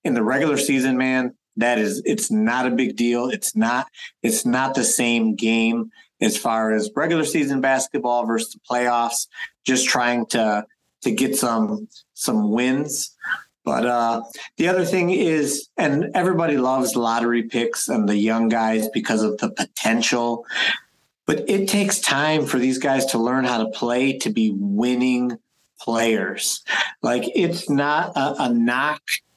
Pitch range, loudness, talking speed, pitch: 115-150 Hz, -21 LUFS, 155 wpm, 125 Hz